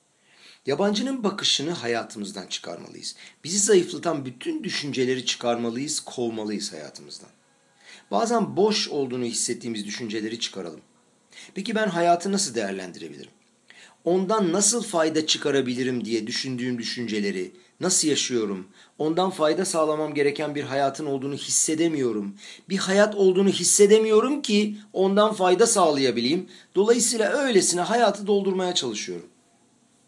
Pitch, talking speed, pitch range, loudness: 155 Hz, 105 wpm, 120-200 Hz, -23 LUFS